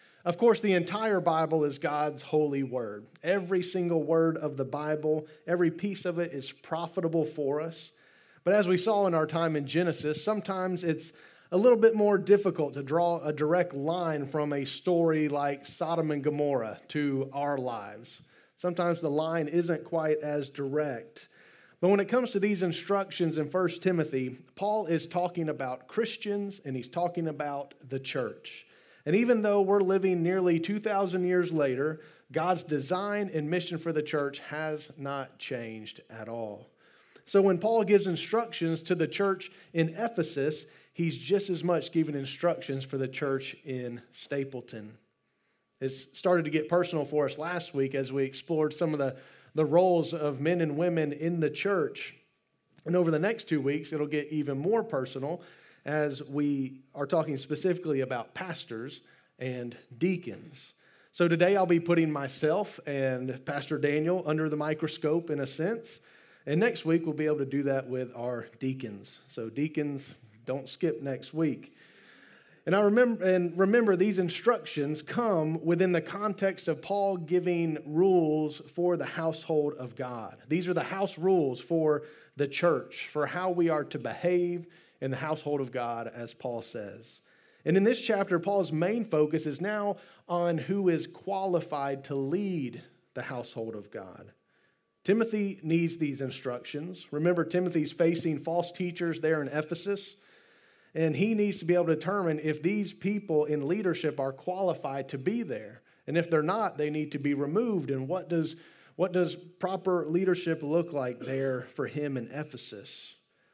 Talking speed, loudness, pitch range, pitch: 165 wpm, -30 LUFS, 145-180 Hz, 160 Hz